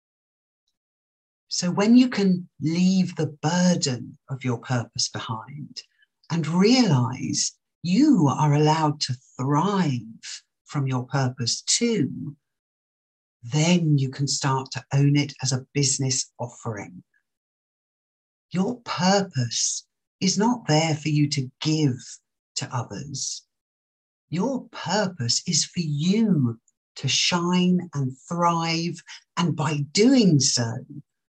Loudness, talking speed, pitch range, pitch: -23 LUFS, 110 wpm, 125-175 Hz, 145 Hz